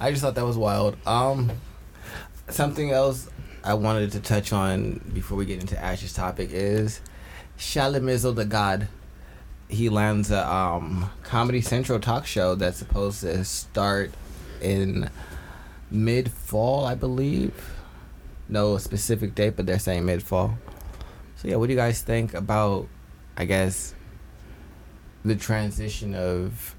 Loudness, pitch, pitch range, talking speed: -26 LUFS, 105 Hz, 95-115 Hz, 135 wpm